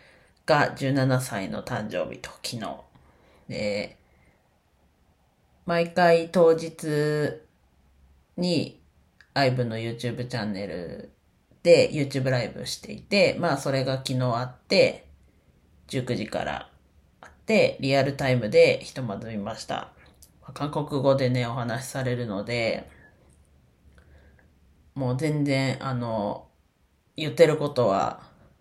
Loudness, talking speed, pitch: -25 LUFS, 215 characters per minute, 120 Hz